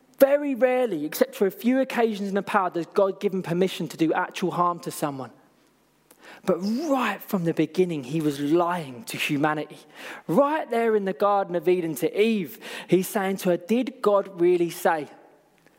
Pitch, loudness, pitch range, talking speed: 190 Hz, -24 LUFS, 170-225 Hz, 180 wpm